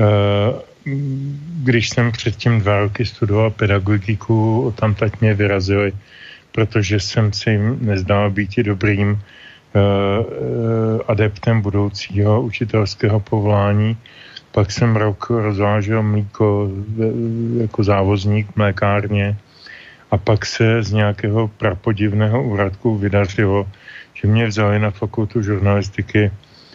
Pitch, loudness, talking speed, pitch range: 105 Hz, -18 LUFS, 100 wpm, 100-115 Hz